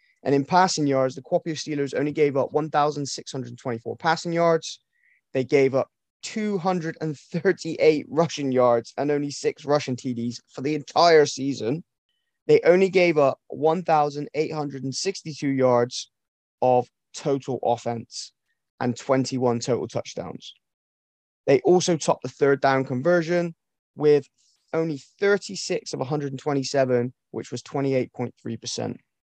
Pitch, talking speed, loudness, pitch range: 145 Hz, 115 wpm, -24 LUFS, 130-160 Hz